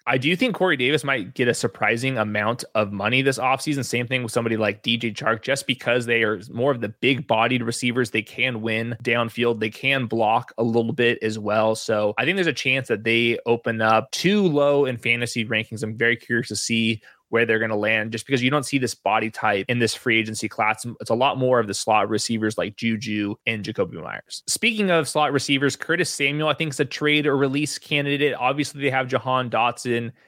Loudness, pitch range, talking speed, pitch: -22 LUFS, 110-135 Hz, 225 wpm, 120 Hz